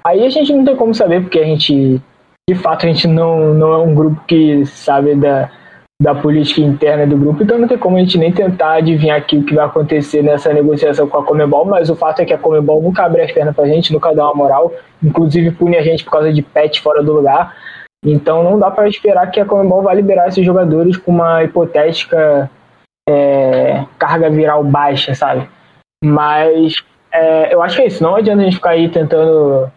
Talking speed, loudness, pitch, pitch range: 220 wpm, -11 LUFS, 160 Hz, 150-170 Hz